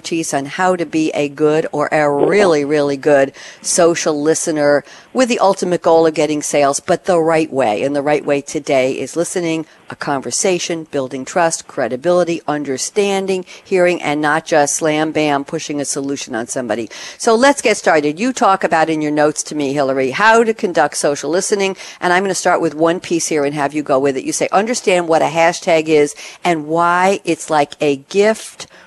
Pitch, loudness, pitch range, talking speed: 160 Hz, -15 LUFS, 145-180 Hz, 195 wpm